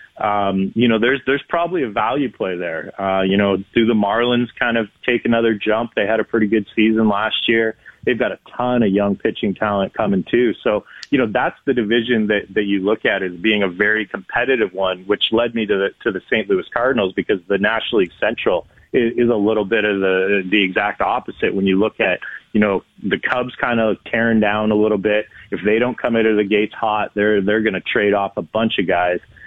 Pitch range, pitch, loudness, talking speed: 100-115 Hz, 105 Hz, -18 LUFS, 235 wpm